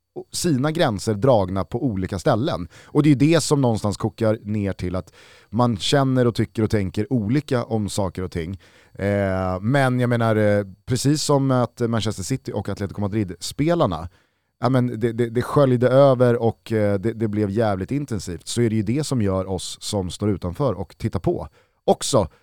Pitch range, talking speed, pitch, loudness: 100-125 Hz, 165 wpm, 115 Hz, -21 LUFS